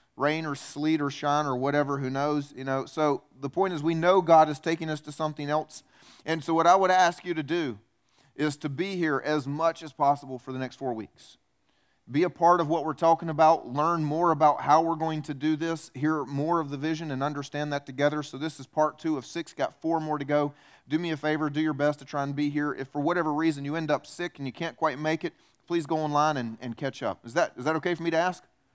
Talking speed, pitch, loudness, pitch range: 265 wpm, 155 Hz, -27 LUFS, 145-165 Hz